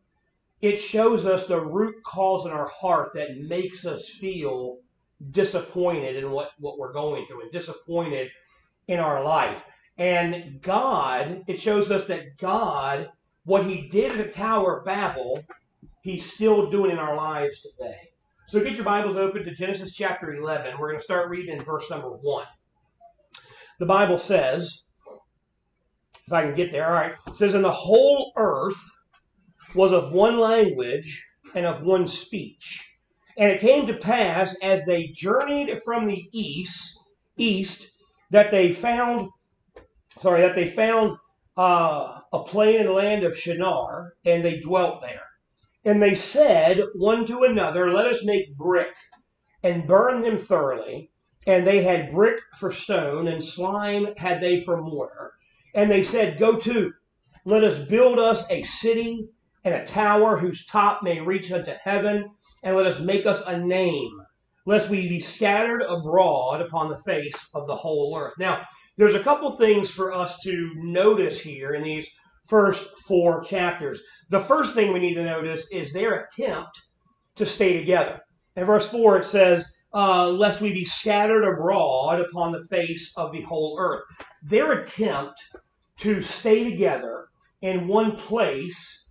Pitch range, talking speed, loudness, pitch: 175-210 Hz, 160 wpm, -23 LUFS, 190 Hz